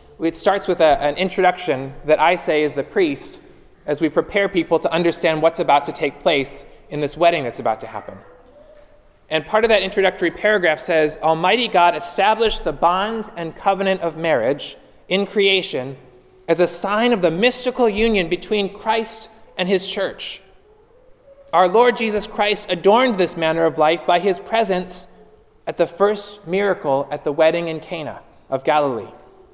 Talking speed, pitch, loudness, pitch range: 170 wpm, 180 Hz, -18 LUFS, 160-215 Hz